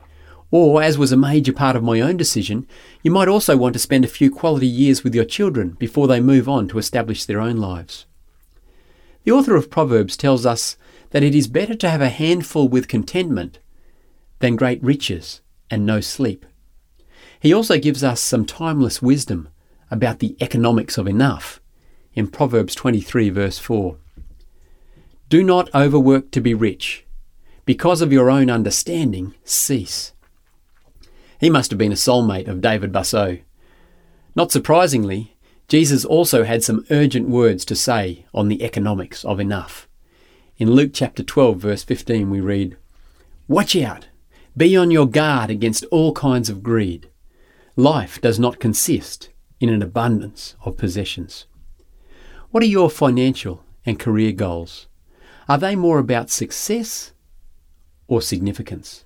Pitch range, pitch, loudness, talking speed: 90-135 Hz, 115 Hz, -18 LUFS, 150 wpm